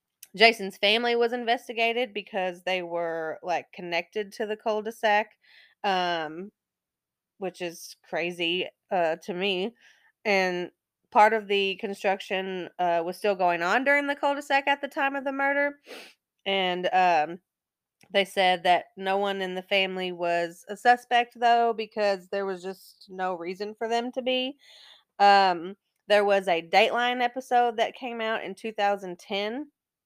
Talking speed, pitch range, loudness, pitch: 155 wpm, 185-230 Hz, -26 LUFS, 200 Hz